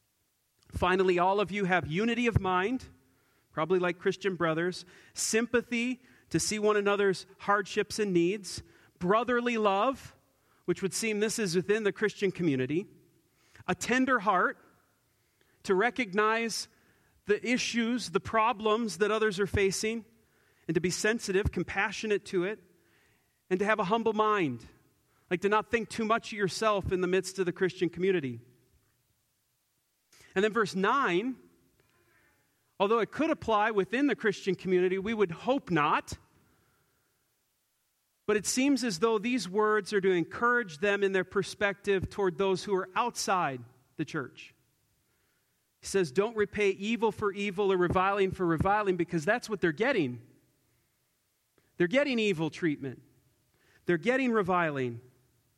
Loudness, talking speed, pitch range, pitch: -29 LUFS, 145 wpm, 175-220 Hz, 195 Hz